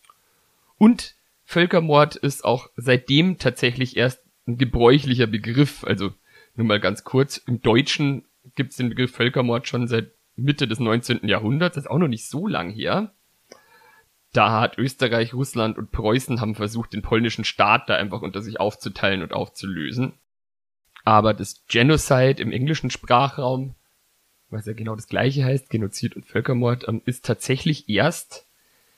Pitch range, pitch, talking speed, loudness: 110-135 Hz, 120 Hz, 150 wpm, -21 LUFS